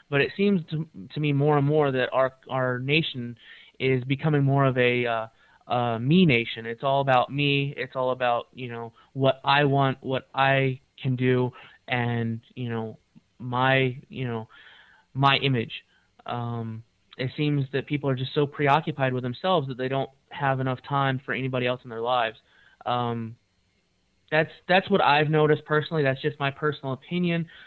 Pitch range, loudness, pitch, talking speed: 125-145 Hz, -25 LUFS, 130 Hz, 175 wpm